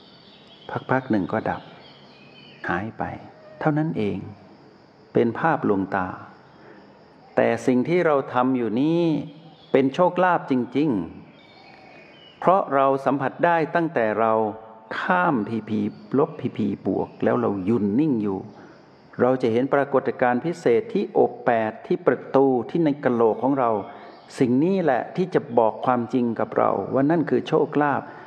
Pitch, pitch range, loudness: 130 Hz, 115-155 Hz, -22 LUFS